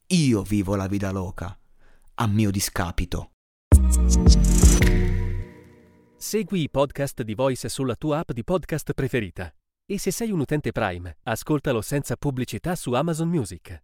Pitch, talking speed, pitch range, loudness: 115 Hz, 135 wpm, 90-145 Hz, -24 LUFS